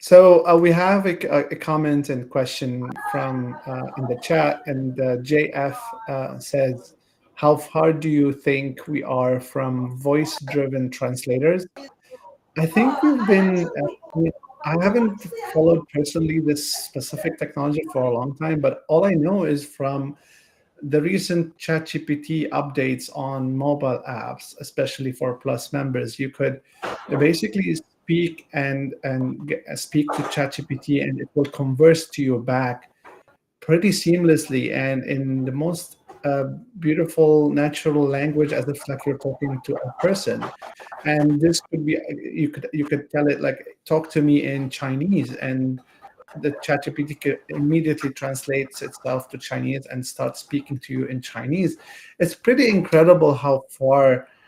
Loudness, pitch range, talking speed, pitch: -21 LUFS, 135-160 Hz, 145 wpm, 145 Hz